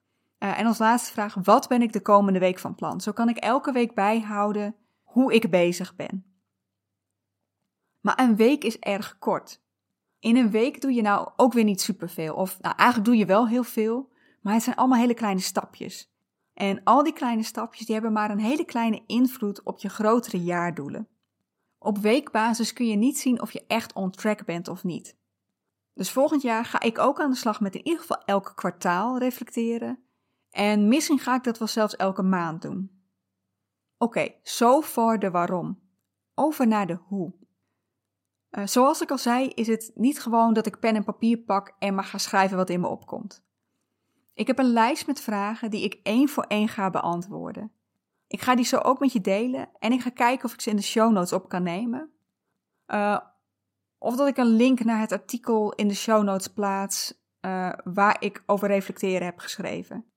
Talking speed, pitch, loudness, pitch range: 200 wpm, 220 Hz, -24 LUFS, 195-240 Hz